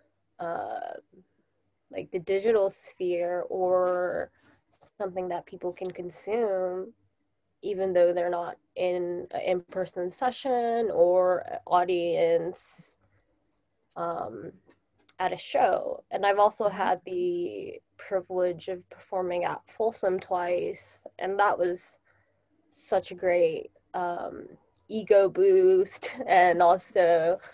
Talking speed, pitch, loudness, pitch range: 105 wpm, 185 Hz, -27 LUFS, 180-225 Hz